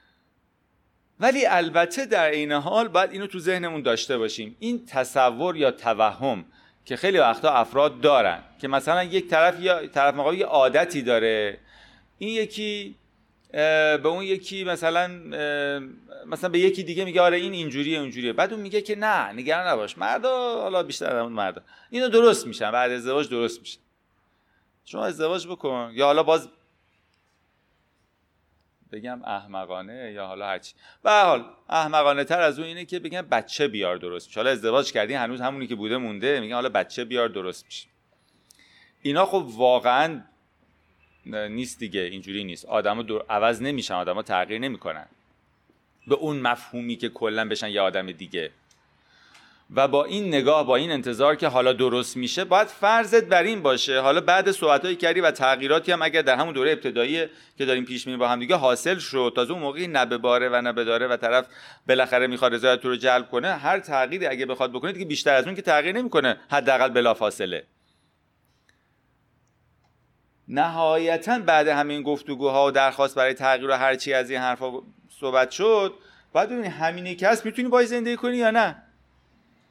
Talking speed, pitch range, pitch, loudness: 165 wpm, 120-175 Hz, 135 Hz, -23 LUFS